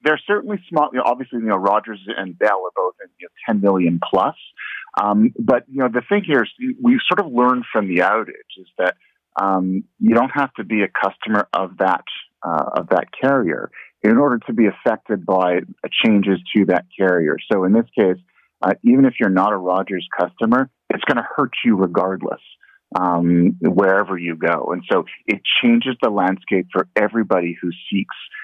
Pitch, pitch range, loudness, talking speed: 105 Hz, 95-140 Hz, -18 LUFS, 195 wpm